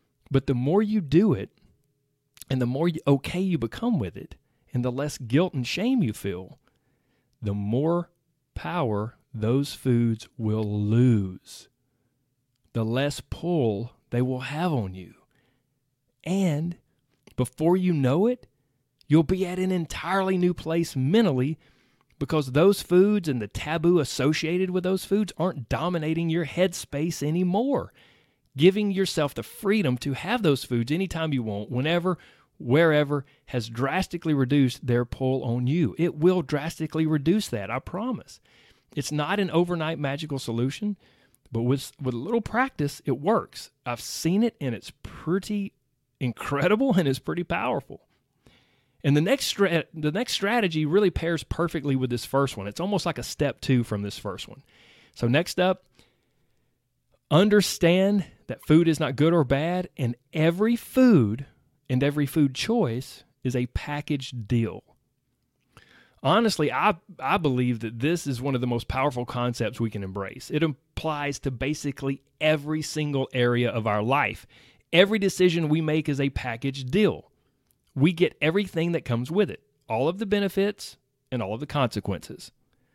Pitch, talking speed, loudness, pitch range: 145 Hz, 155 wpm, -25 LUFS, 125-175 Hz